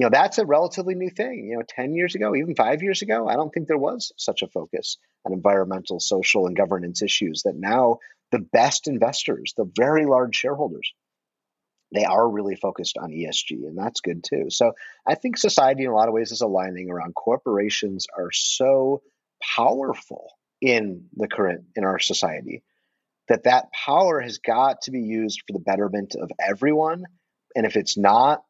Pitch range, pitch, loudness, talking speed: 100-155 Hz, 115 Hz, -22 LUFS, 185 wpm